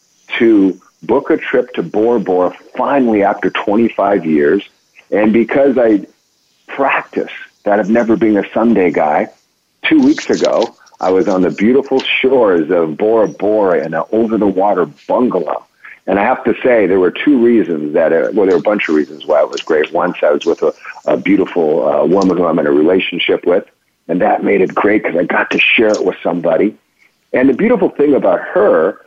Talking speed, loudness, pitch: 200 wpm, -13 LUFS, 135 Hz